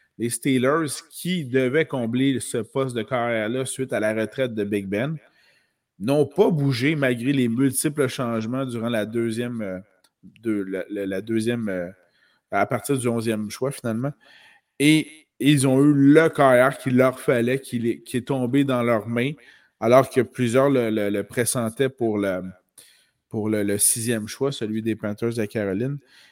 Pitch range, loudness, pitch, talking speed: 110-135 Hz, -22 LUFS, 125 Hz, 155 wpm